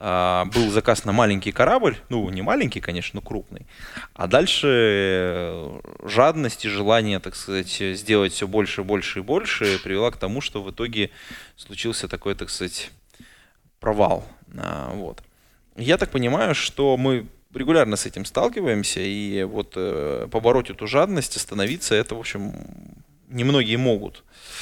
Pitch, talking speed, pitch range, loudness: 105 Hz, 145 wpm, 95-115 Hz, -22 LUFS